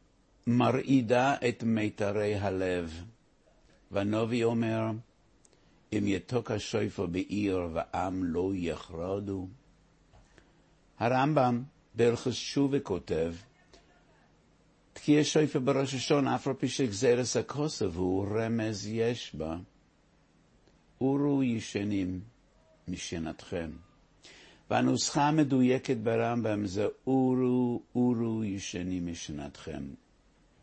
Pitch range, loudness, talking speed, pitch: 100-130 Hz, -30 LUFS, 80 wpm, 115 Hz